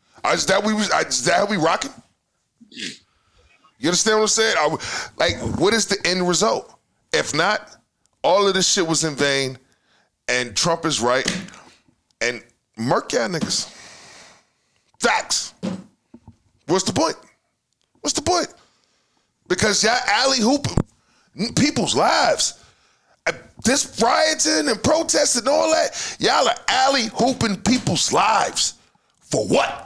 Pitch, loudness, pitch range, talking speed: 215 Hz, -19 LUFS, 175-260 Hz, 130 wpm